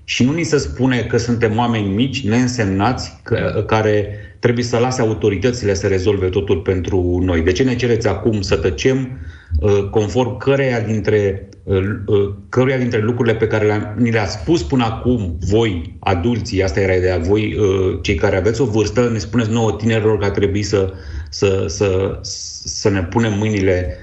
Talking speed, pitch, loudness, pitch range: 175 wpm, 105 Hz, -17 LUFS, 95-120 Hz